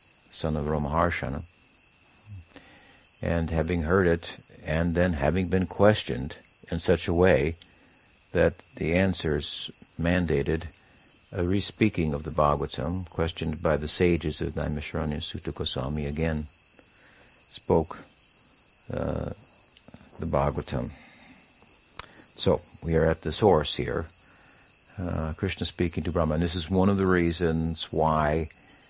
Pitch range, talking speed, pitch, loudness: 75-90 Hz, 120 wpm, 85 Hz, -27 LUFS